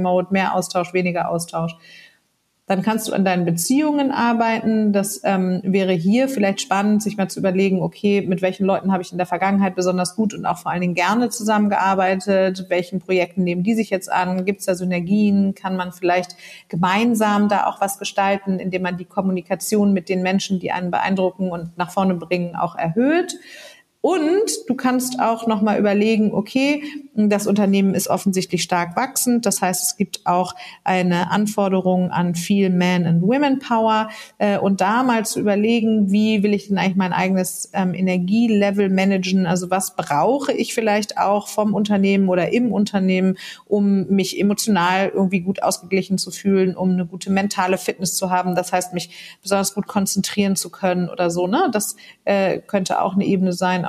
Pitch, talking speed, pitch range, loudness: 195 Hz, 180 wpm, 185-210 Hz, -19 LUFS